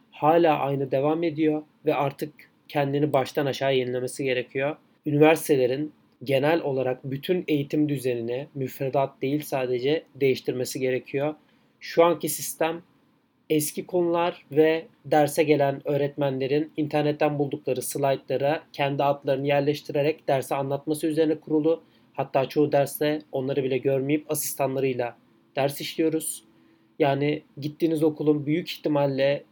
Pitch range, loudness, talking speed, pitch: 135-155 Hz, -25 LUFS, 110 wpm, 145 Hz